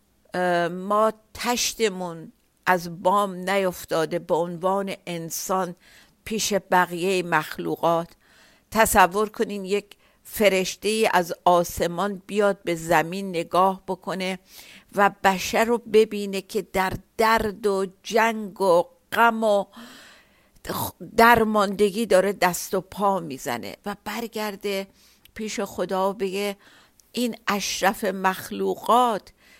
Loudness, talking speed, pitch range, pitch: -23 LUFS, 95 wpm, 180-210 Hz, 195 Hz